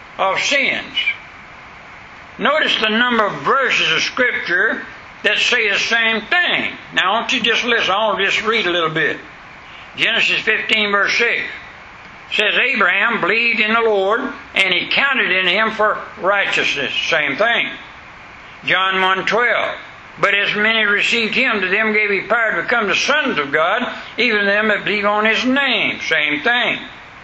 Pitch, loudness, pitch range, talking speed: 220 Hz, -15 LUFS, 205-235 Hz, 160 wpm